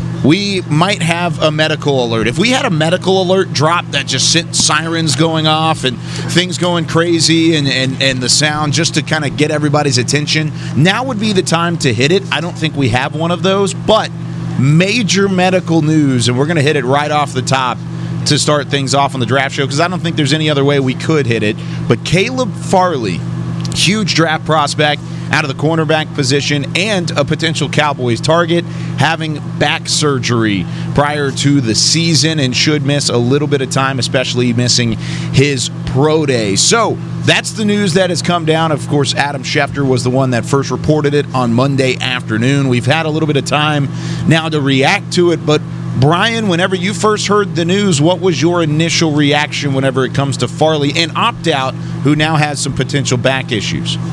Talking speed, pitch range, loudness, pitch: 205 wpm, 135-165 Hz, -13 LUFS, 150 Hz